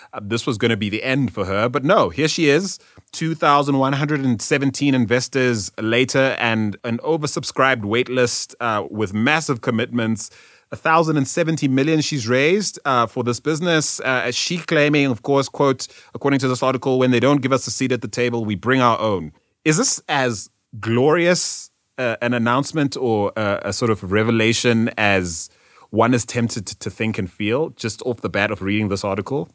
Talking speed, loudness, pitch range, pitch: 175 wpm, -19 LUFS, 110-140 Hz, 125 Hz